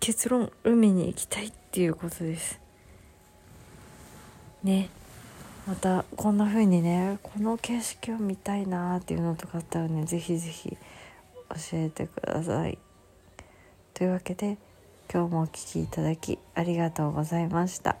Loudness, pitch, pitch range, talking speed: -29 LUFS, 170 Hz, 150-195 Hz, 285 characters per minute